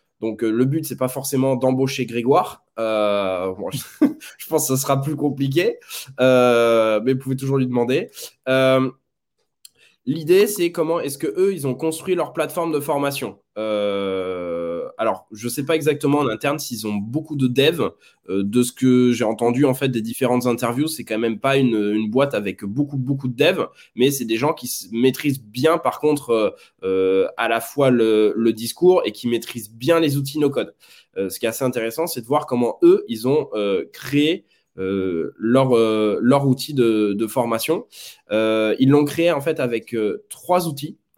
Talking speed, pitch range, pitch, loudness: 195 wpm, 115-145 Hz, 130 Hz, -20 LUFS